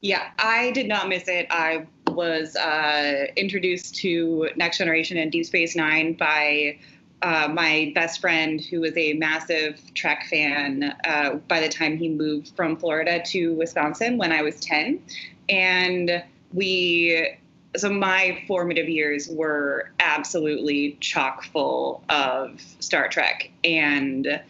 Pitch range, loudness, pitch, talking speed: 155-175 Hz, -22 LUFS, 165 Hz, 135 wpm